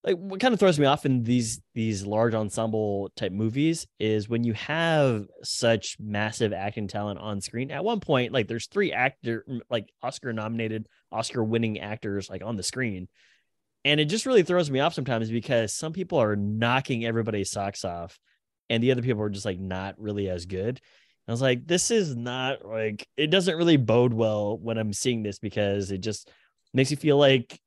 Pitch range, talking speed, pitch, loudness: 105-135 Hz, 200 wpm, 115 Hz, -26 LUFS